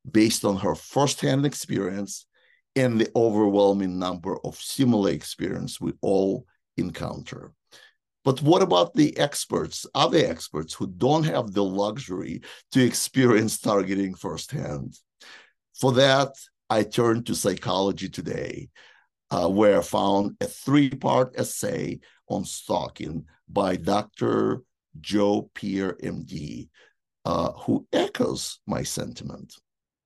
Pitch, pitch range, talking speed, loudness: 105 Hz, 100-130 Hz, 115 wpm, -25 LUFS